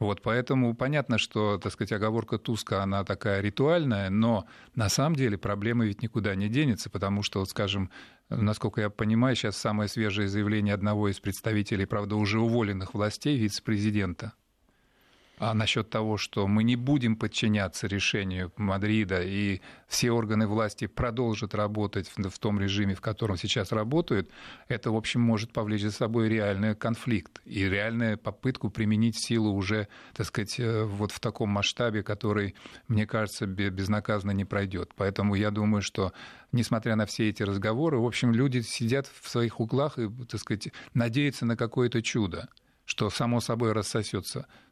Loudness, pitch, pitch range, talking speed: -29 LUFS, 110 Hz, 105-115 Hz, 155 wpm